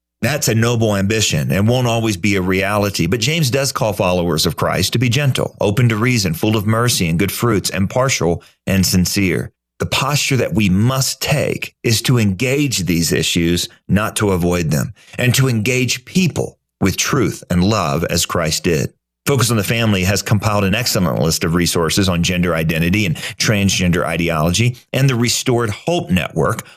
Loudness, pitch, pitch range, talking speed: -16 LUFS, 110 Hz, 90-125 Hz, 180 wpm